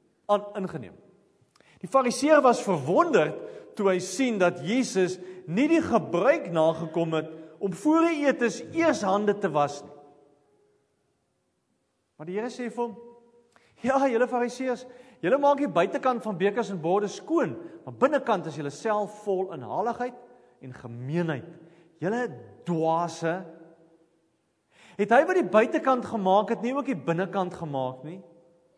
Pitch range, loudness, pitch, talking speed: 165-245 Hz, -26 LUFS, 200 Hz, 145 wpm